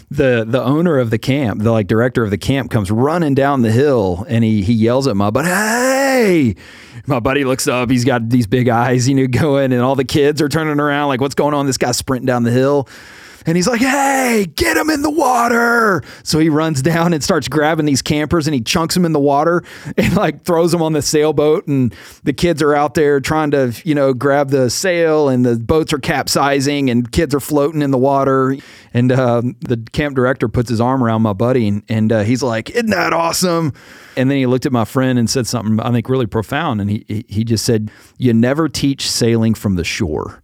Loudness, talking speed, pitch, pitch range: -15 LUFS, 230 wpm, 135 Hz, 120-155 Hz